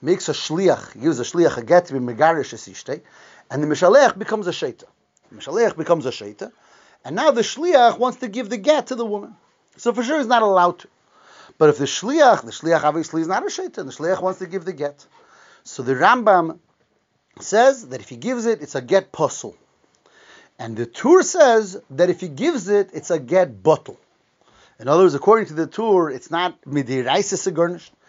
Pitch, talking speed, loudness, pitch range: 185 Hz, 205 wpm, -19 LUFS, 160-235 Hz